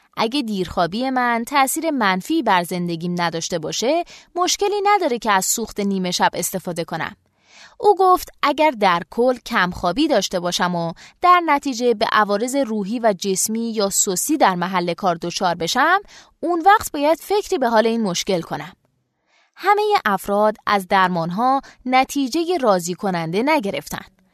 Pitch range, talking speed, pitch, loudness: 180-290 Hz, 145 wpm, 215 Hz, -19 LUFS